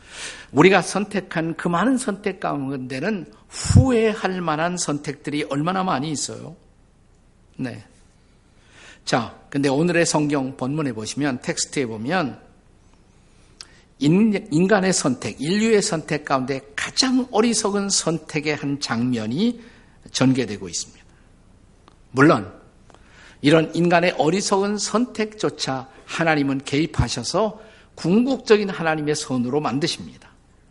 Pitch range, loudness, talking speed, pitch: 130-195 Hz, -21 LUFS, 250 characters per minute, 155 Hz